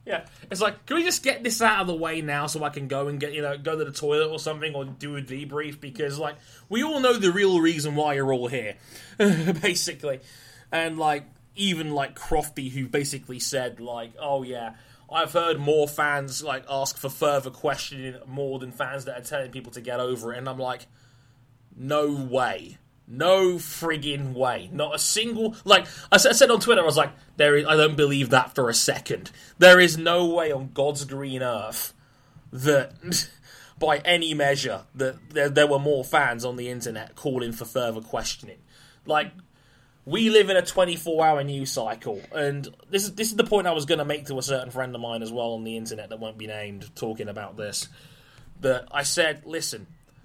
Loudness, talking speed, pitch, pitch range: -24 LUFS, 205 wpm, 145 Hz, 130-160 Hz